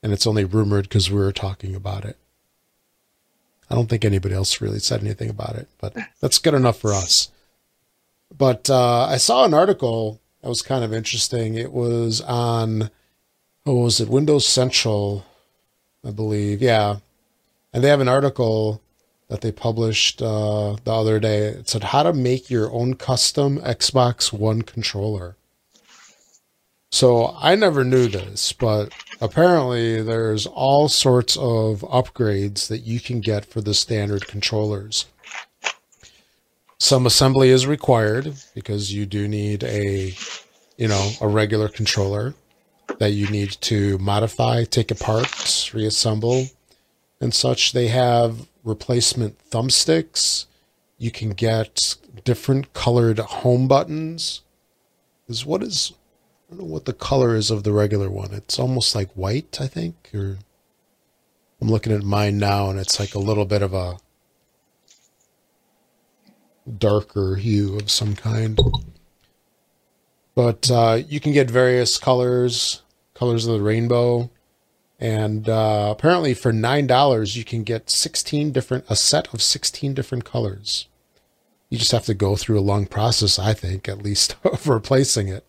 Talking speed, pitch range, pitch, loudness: 145 wpm, 105-125 Hz, 110 Hz, -20 LUFS